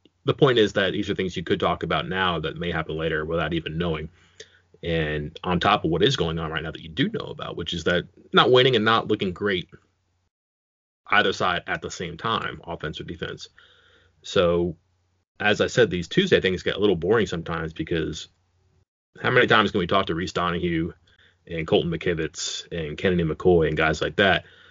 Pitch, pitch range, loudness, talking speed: 85 Hz, 80-90 Hz, -23 LUFS, 205 wpm